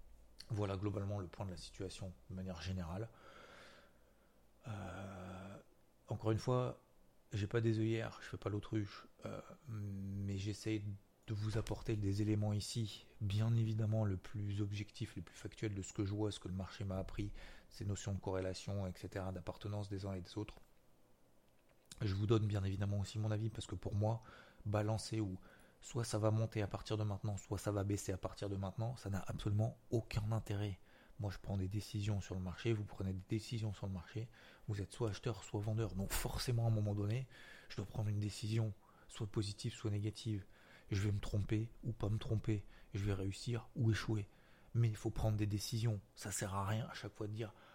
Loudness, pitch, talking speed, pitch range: -42 LUFS, 105 Hz, 200 wpm, 100-110 Hz